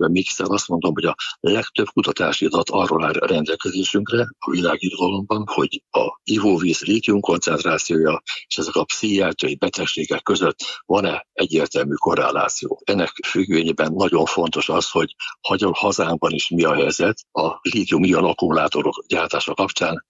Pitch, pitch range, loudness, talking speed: 100 Hz, 90-110 Hz, -20 LUFS, 135 wpm